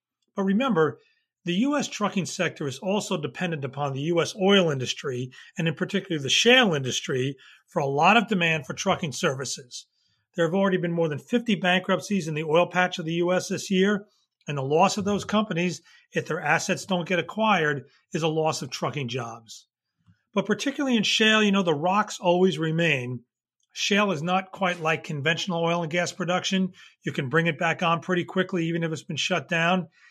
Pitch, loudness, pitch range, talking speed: 175 Hz, -25 LUFS, 160-195 Hz, 195 wpm